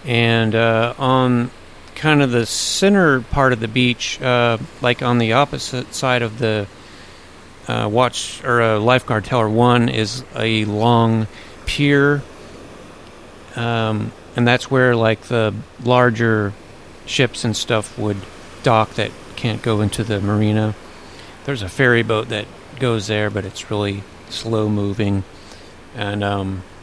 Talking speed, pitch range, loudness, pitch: 140 wpm, 100-120 Hz, -18 LUFS, 110 Hz